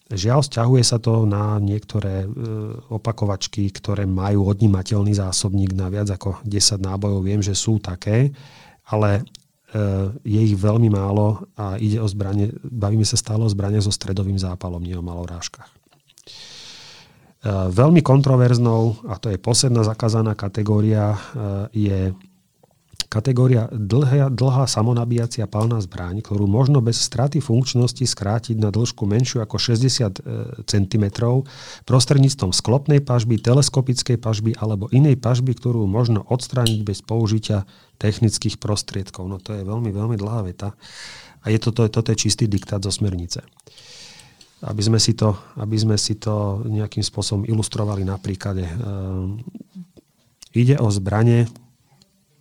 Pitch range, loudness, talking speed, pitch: 100-120 Hz, -20 LUFS, 130 wpm, 110 Hz